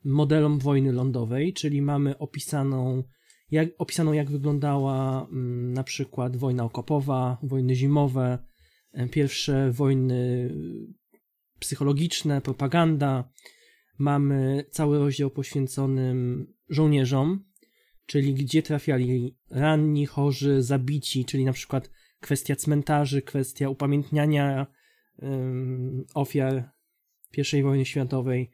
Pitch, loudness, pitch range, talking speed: 140 Hz, -26 LUFS, 130-145 Hz, 90 wpm